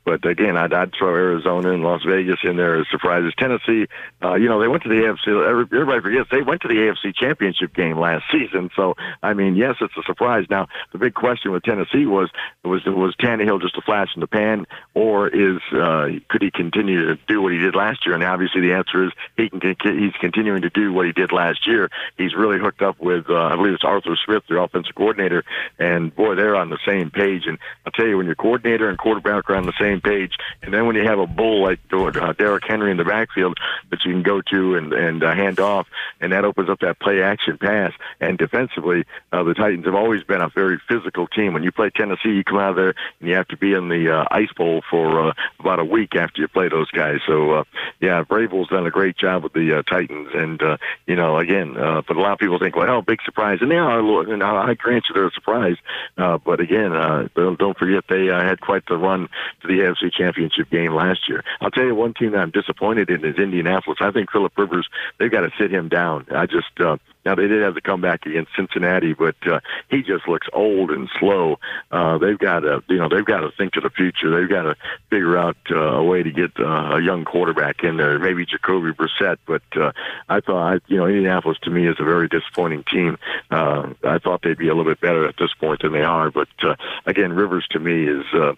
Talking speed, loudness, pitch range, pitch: 245 wpm, -19 LUFS, 85-100 Hz, 95 Hz